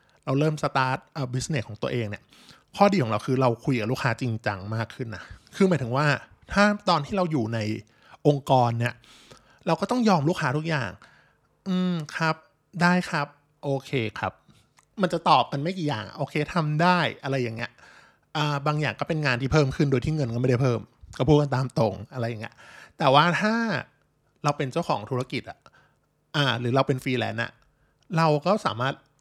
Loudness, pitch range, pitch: -25 LUFS, 125-155 Hz, 140 Hz